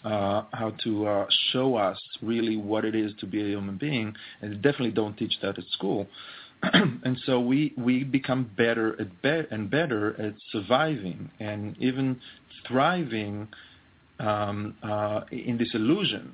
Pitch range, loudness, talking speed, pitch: 105-130 Hz, -27 LUFS, 160 wpm, 110 Hz